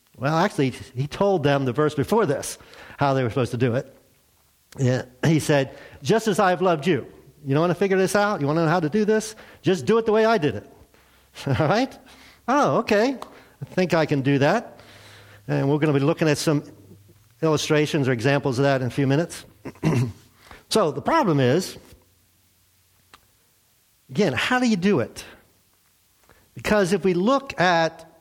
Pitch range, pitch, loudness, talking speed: 125-185 Hz, 145 Hz, -22 LUFS, 190 wpm